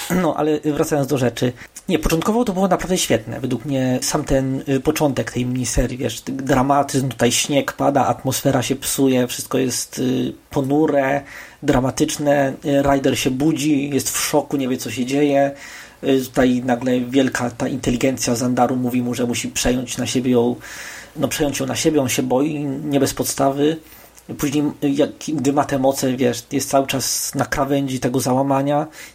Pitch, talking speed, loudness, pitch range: 135 Hz, 165 wpm, -19 LUFS, 125-145 Hz